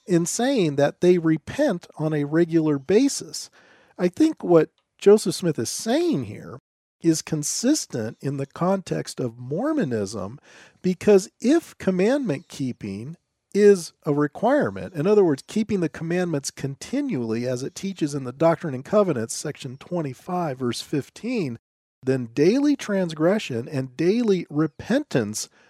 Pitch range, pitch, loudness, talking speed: 140-200 Hz, 165 Hz, -23 LUFS, 130 wpm